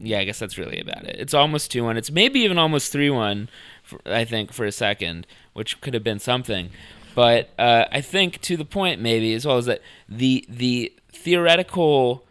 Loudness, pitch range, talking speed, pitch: -21 LUFS, 110-150 Hz, 205 wpm, 120 Hz